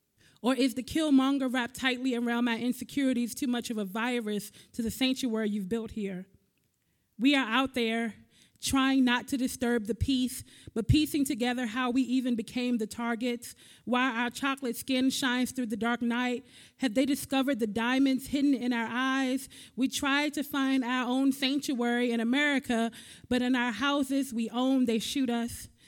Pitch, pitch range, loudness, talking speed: 250 Hz, 235-265 Hz, -29 LUFS, 175 wpm